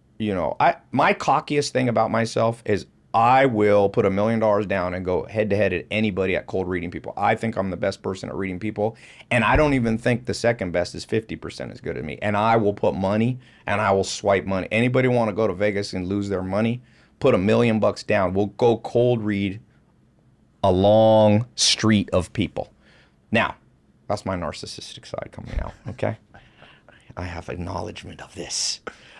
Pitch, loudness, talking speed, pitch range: 105 Hz, -22 LUFS, 200 wpm, 95-115 Hz